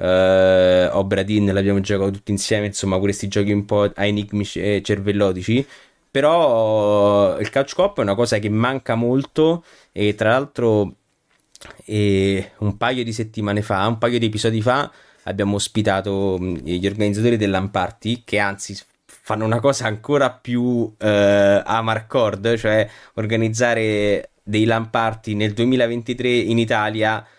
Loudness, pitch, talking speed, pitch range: -19 LUFS, 105 Hz, 140 wpm, 100-115 Hz